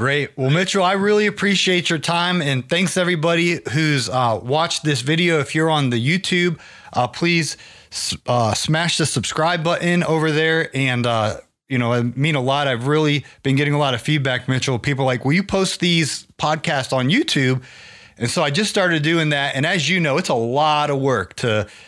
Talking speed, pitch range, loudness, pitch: 205 wpm, 130-170 Hz, -19 LUFS, 150 Hz